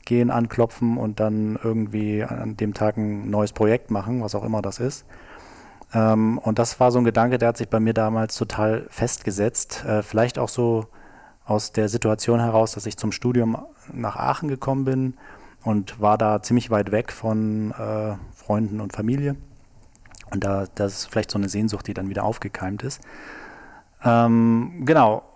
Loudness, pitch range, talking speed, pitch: -23 LUFS, 105-120 Hz, 165 wpm, 110 Hz